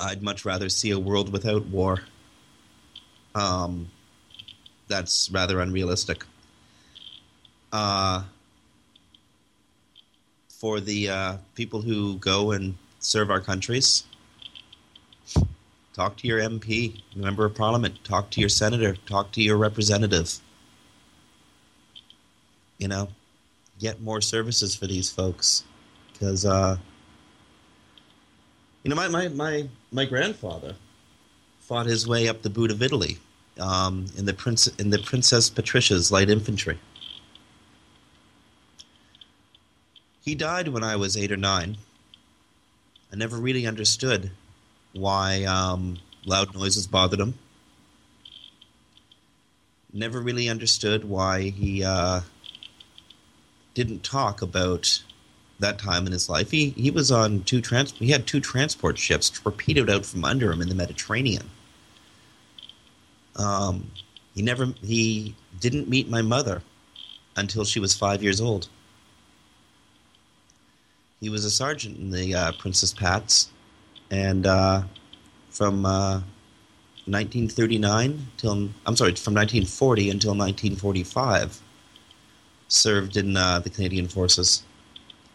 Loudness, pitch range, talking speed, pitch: -24 LUFS, 95-110 Hz, 115 wpm, 100 Hz